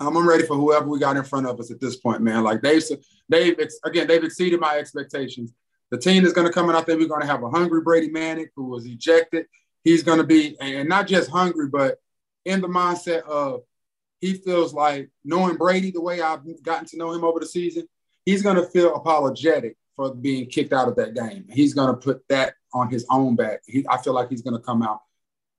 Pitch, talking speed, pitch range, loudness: 160 Hz, 235 wpm, 135-170 Hz, -21 LUFS